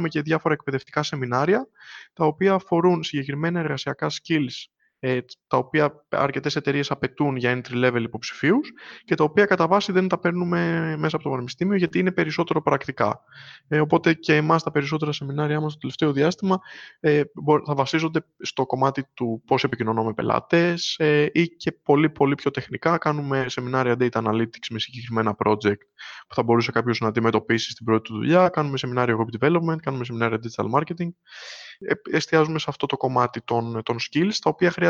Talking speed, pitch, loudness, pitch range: 165 wpm, 145 Hz, -23 LUFS, 125-165 Hz